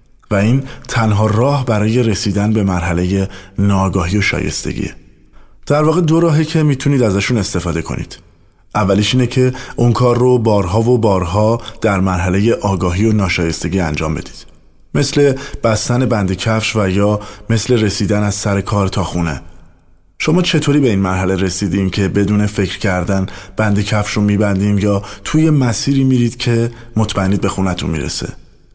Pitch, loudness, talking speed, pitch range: 105 Hz, -15 LUFS, 150 wpm, 95-120 Hz